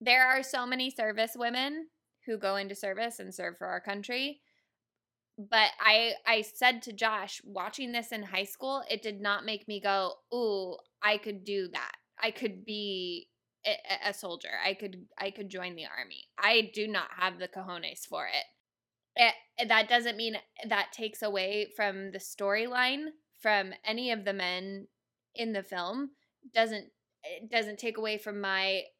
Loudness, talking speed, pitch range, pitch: -31 LUFS, 170 wpm, 195-235 Hz, 215 Hz